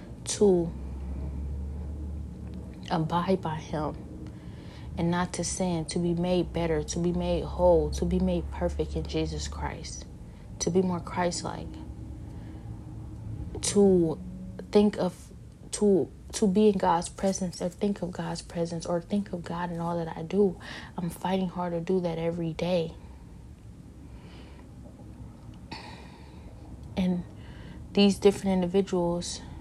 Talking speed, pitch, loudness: 130 wpm, 170 Hz, -28 LUFS